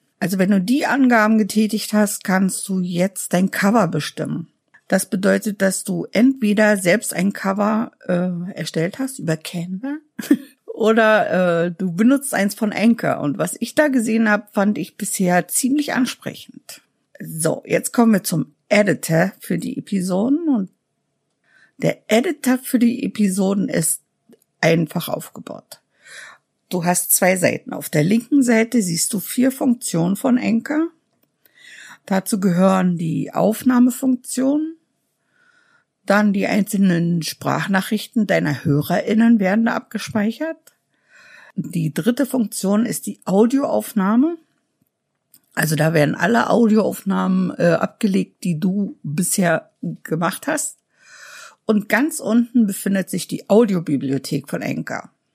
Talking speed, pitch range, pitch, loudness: 125 wpm, 185-240 Hz, 210 Hz, -19 LUFS